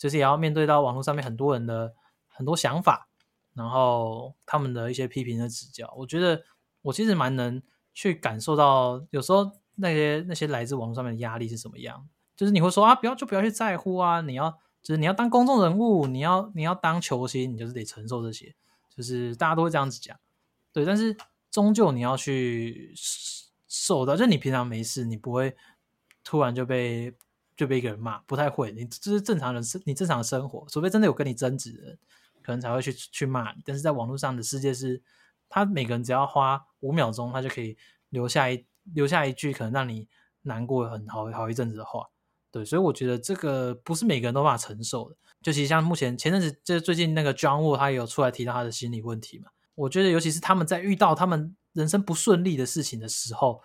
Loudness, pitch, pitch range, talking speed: -26 LUFS, 140 Hz, 125-170 Hz, 340 characters per minute